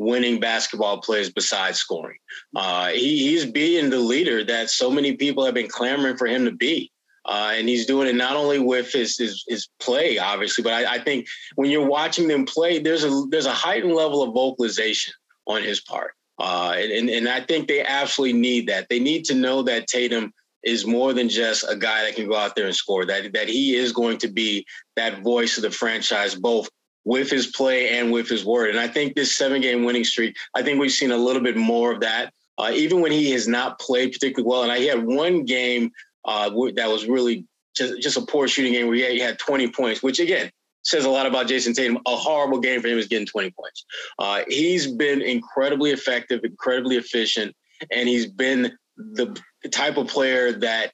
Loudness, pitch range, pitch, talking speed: -21 LUFS, 120-140 Hz, 125 Hz, 220 wpm